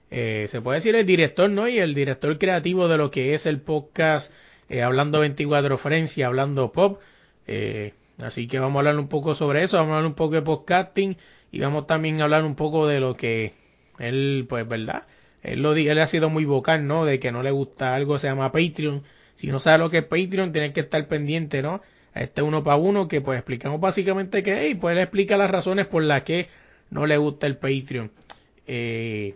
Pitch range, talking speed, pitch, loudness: 135-160 Hz, 220 wpm, 150 Hz, -23 LUFS